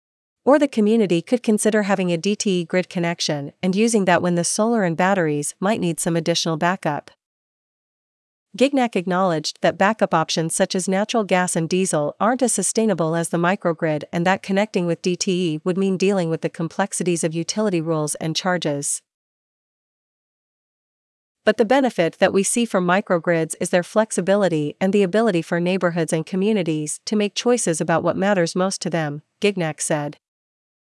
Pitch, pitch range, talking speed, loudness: 185 Hz, 170-205 Hz, 165 wpm, -20 LUFS